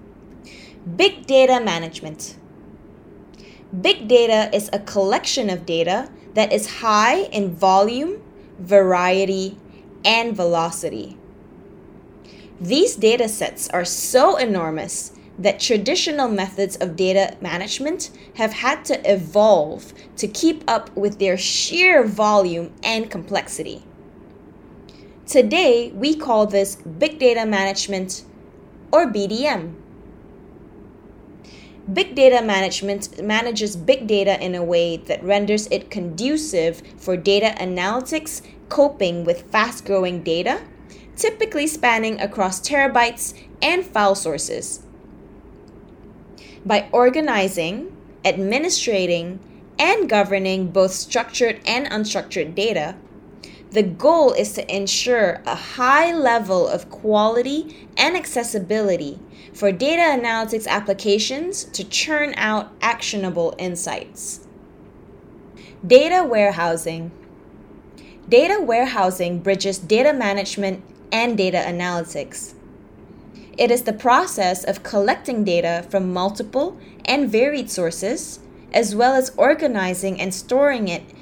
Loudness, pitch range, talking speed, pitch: -19 LUFS, 190-255 Hz, 105 wpm, 210 Hz